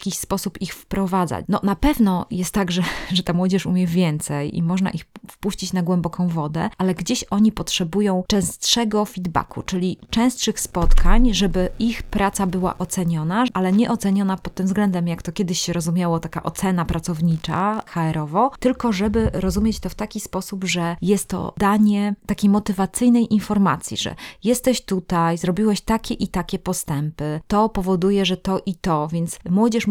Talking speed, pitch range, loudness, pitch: 165 wpm, 175-210 Hz, -21 LUFS, 190 Hz